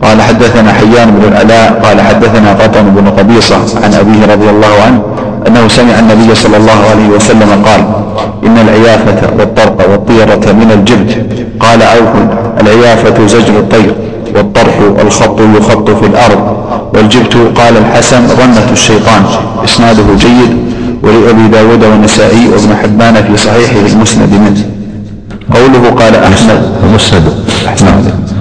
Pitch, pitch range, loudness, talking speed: 110 Hz, 105-115 Hz, -4 LUFS, 125 wpm